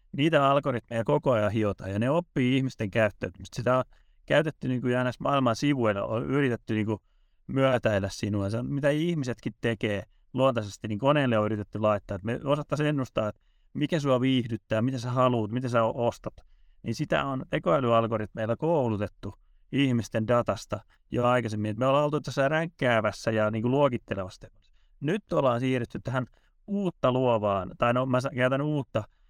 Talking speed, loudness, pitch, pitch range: 160 wpm, -27 LUFS, 120 Hz, 110-135 Hz